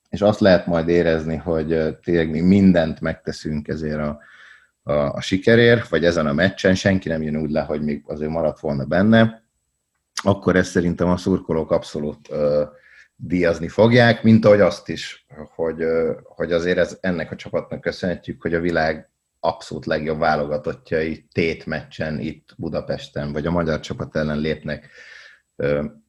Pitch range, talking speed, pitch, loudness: 75-90 Hz, 160 wpm, 80 Hz, -20 LUFS